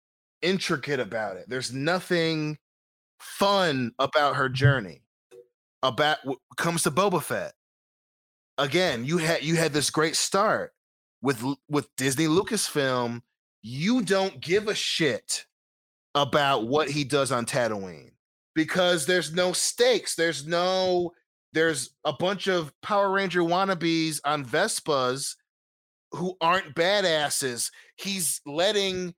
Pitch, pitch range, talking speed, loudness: 155 Hz, 135-180 Hz, 120 wpm, -25 LUFS